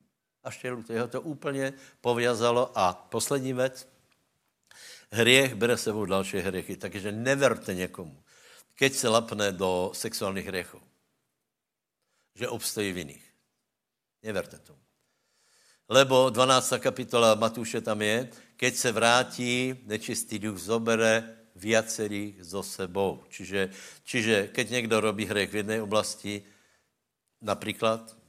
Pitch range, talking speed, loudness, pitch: 100-125 Hz, 115 wpm, -27 LUFS, 110 Hz